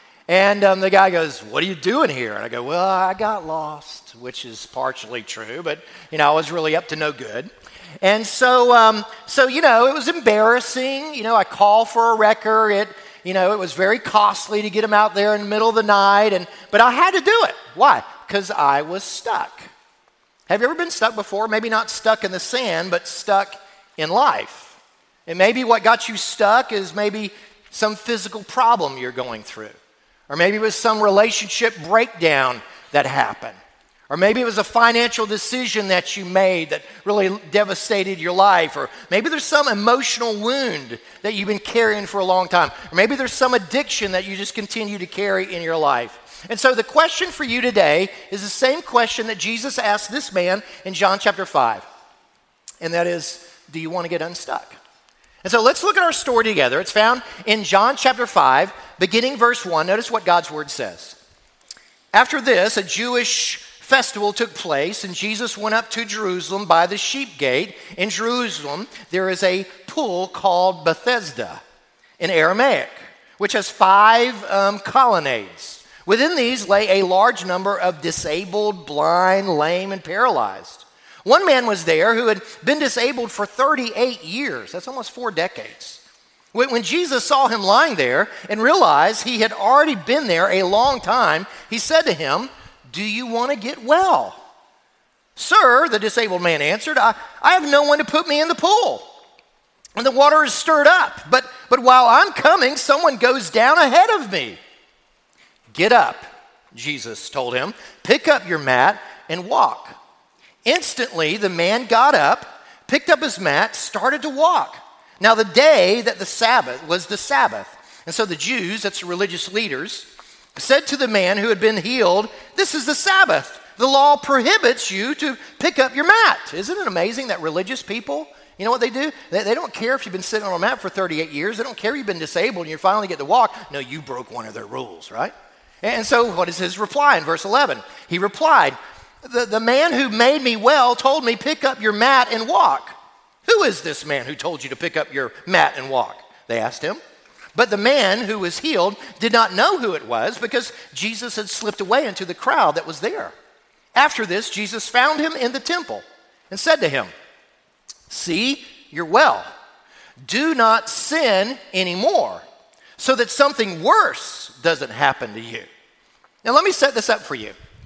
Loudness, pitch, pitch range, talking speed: -18 LUFS, 220 Hz, 190-255 Hz, 190 wpm